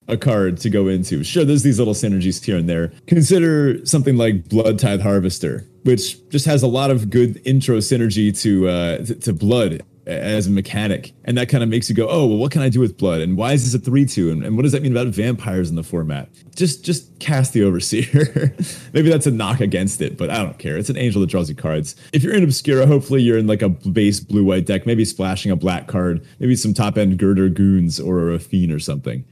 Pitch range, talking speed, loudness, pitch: 95-135 Hz, 235 wpm, -18 LUFS, 110 Hz